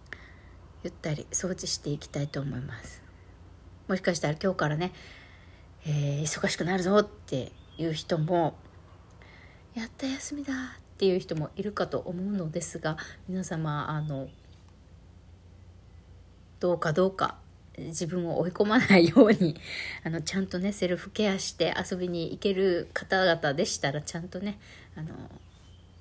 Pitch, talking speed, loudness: 160 Hz, 280 characters per minute, -29 LUFS